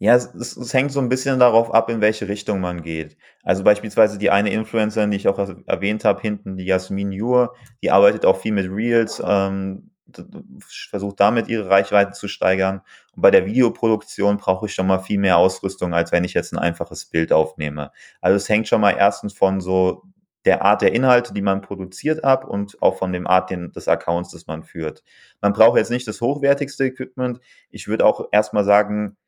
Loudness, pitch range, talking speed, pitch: -19 LUFS, 95-115 Hz, 205 wpm, 100 Hz